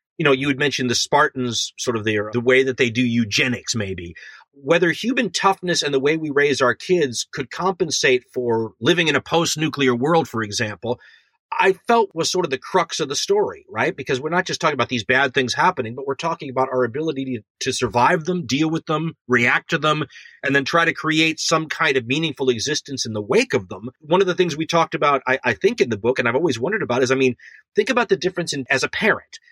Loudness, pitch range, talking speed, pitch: -20 LUFS, 125-165 Hz, 245 wpm, 145 Hz